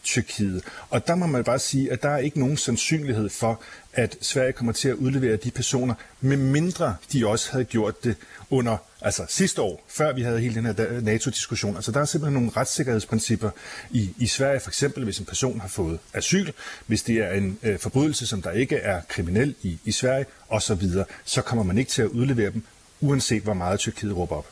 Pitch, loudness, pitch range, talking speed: 120 Hz, -25 LUFS, 110-135 Hz, 210 wpm